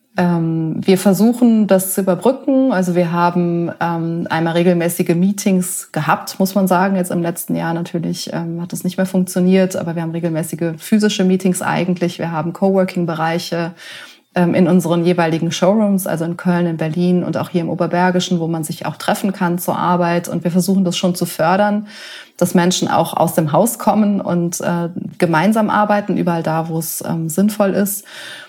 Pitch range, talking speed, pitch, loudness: 170-195 Hz, 170 wpm, 180 Hz, -16 LUFS